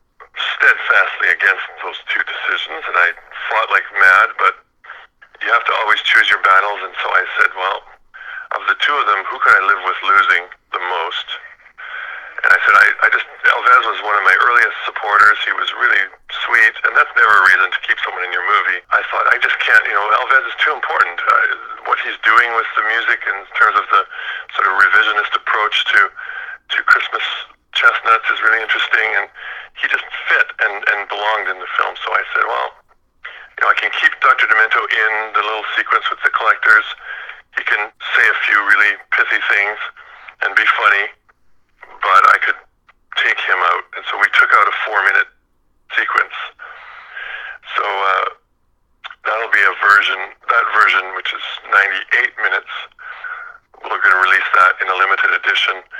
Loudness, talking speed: -14 LUFS, 185 wpm